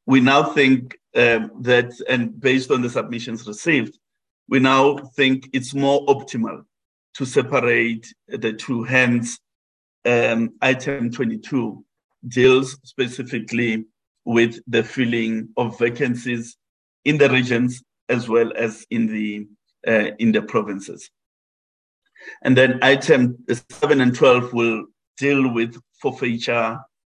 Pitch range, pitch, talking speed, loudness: 115-130 Hz, 125 Hz, 120 wpm, -19 LUFS